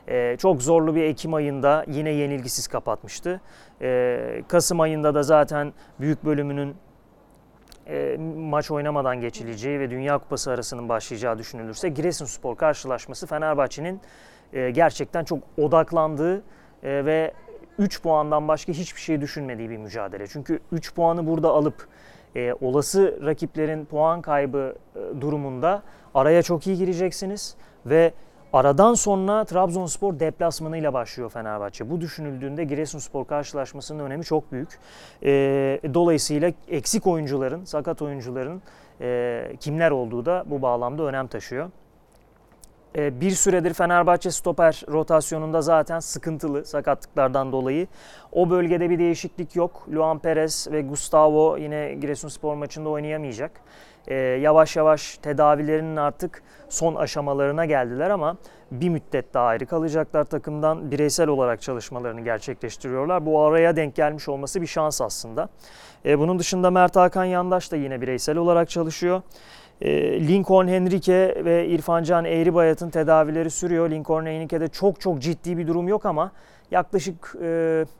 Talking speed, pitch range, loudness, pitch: 125 wpm, 140-170 Hz, -23 LUFS, 155 Hz